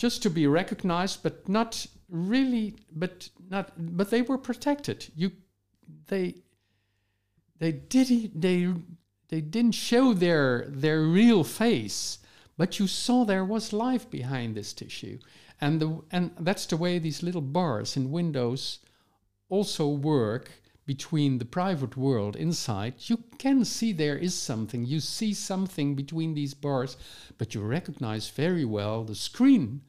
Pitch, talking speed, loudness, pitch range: 160 Hz, 145 wpm, -28 LUFS, 130-195 Hz